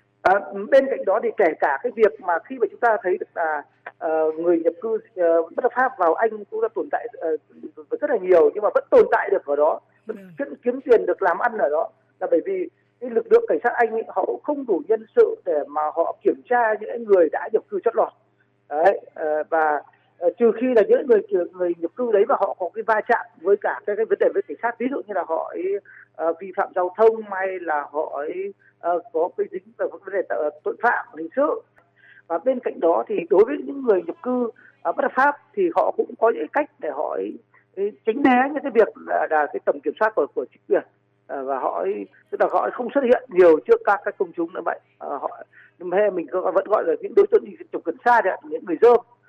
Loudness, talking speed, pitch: -22 LUFS, 255 wpm, 250 Hz